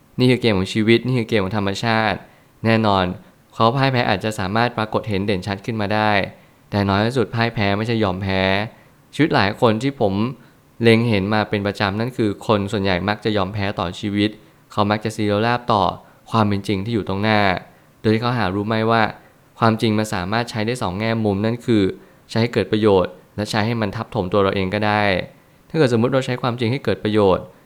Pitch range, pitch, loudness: 100-115 Hz, 110 Hz, -20 LUFS